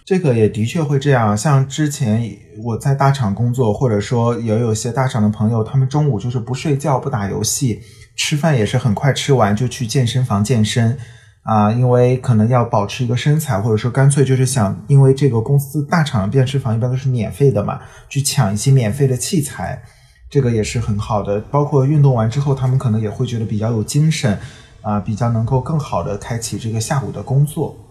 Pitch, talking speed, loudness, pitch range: 125 Hz, 320 characters per minute, -17 LUFS, 110-135 Hz